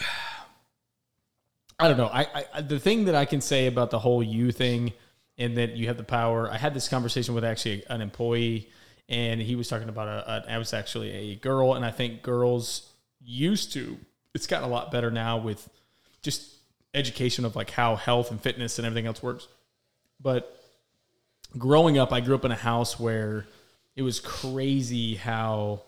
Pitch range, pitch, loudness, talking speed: 115-130 Hz, 120 Hz, -27 LUFS, 190 wpm